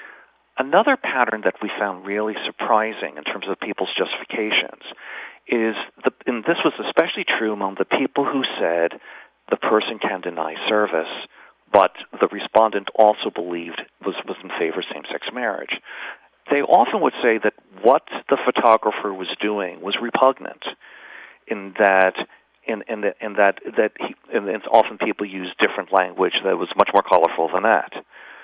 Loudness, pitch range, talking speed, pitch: -21 LUFS, 95-110 Hz, 160 wpm, 105 Hz